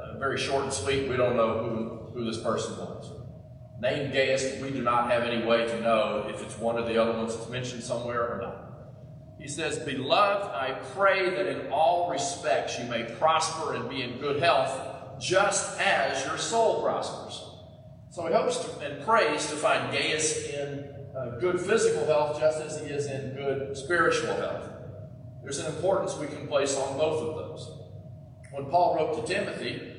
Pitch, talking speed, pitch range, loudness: 135 Hz, 185 wpm, 120-155 Hz, -28 LUFS